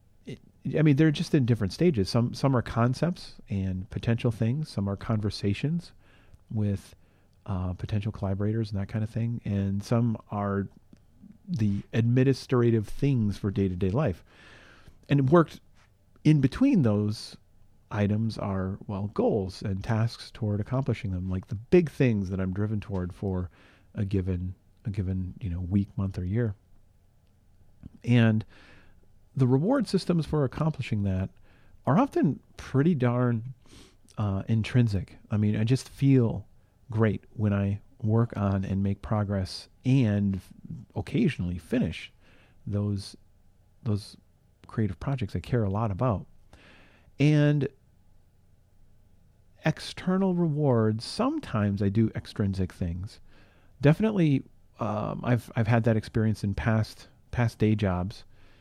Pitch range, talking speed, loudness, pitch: 95-120 Hz, 135 wpm, -28 LUFS, 105 Hz